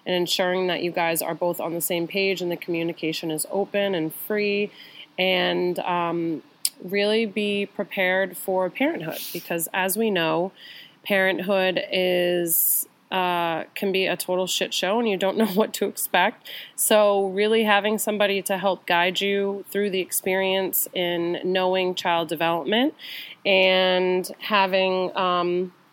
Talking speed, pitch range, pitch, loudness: 145 wpm, 175-200 Hz, 185 Hz, -23 LUFS